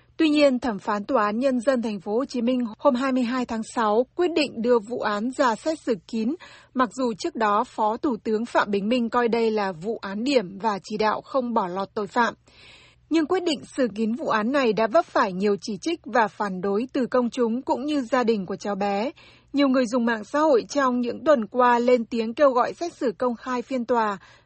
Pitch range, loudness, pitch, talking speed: 220-270 Hz, -24 LUFS, 245 Hz, 240 wpm